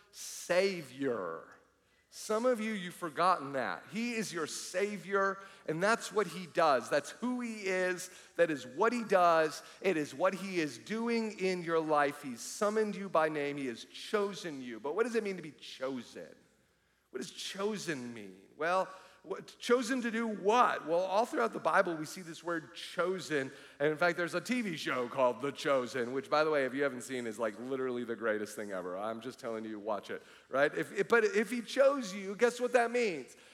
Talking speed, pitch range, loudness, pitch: 205 wpm, 140-215 Hz, -33 LUFS, 175 Hz